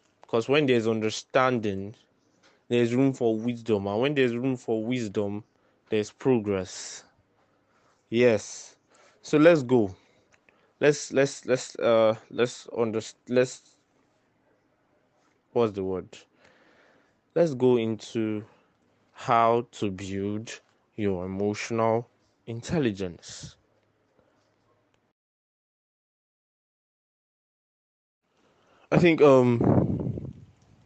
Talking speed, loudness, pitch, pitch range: 80 wpm, -26 LUFS, 115 Hz, 105-125 Hz